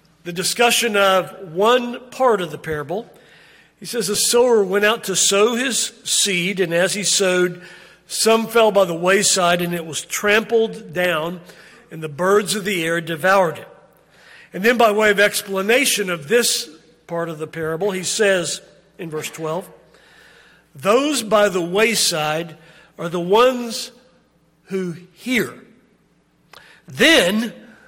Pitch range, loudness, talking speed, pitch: 170-225 Hz, -18 LUFS, 145 wpm, 195 Hz